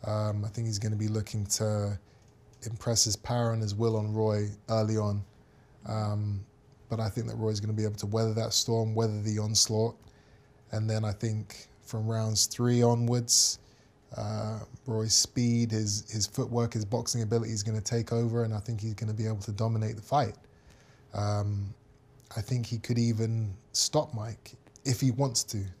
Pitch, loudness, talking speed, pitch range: 110 Hz, -30 LUFS, 190 wpm, 105-120 Hz